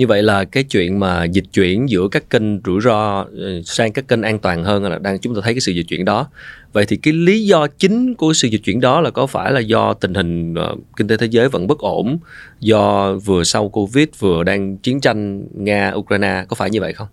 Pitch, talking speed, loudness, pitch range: 105 Hz, 240 wpm, -16 LUFS, 95-125 Hz